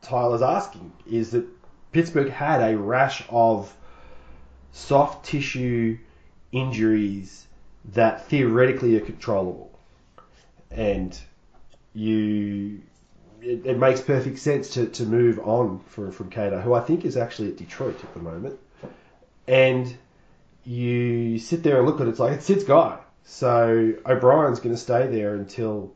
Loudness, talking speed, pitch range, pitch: -23 LUFS, 140 wpm, 105-130 Hz, 120 Hz